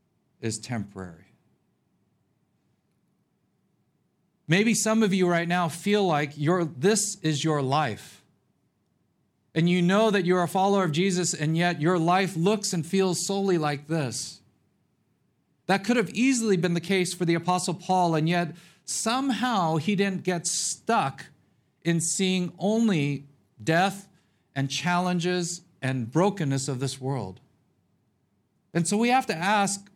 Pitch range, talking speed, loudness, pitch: 150-195 Hz, 140 wpm, -25 LUFS, 175 Hz